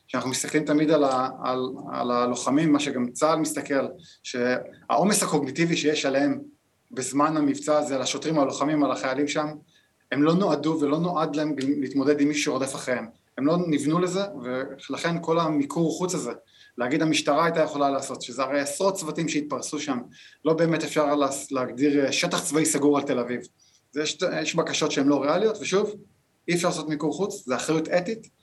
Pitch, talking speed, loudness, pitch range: 150 Hz, 175 wpm, -25 LUFS, 140-160 Hz